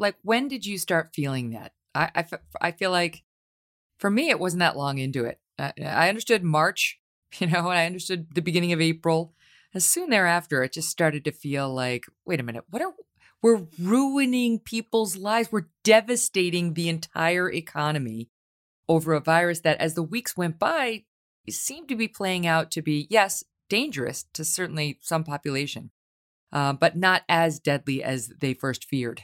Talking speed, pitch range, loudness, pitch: 180 wpm, 140-200 Hz, -25 LUFS, 165 Hz